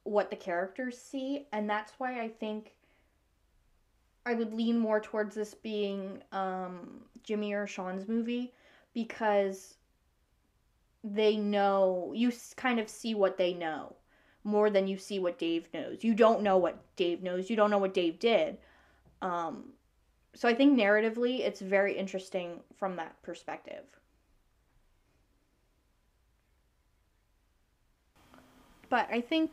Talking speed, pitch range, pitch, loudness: 130 wpm, 195-240 Hz, 210 Hz, -31 LUFS